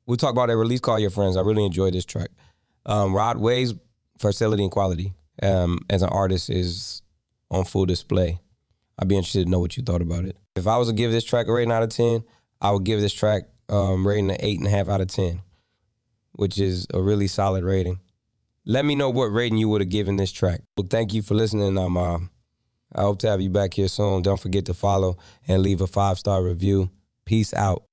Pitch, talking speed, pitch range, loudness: 100 Hz, 225 wpm, 95-110 Hz, -23 LUFS